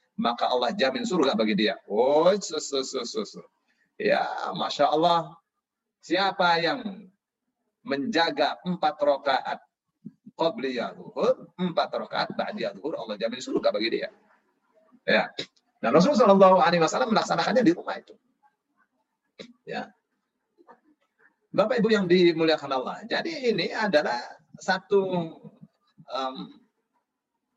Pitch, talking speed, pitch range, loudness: 195 Hz, 105 wpm, 165-235 Hz, -25 LUFS